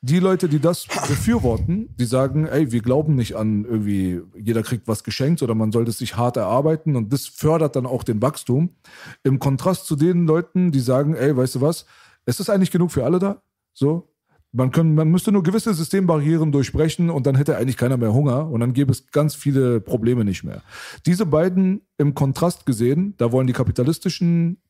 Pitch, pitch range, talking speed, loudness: 140 Hz, 125-165 Hz, 205 wpm, -20 LUFS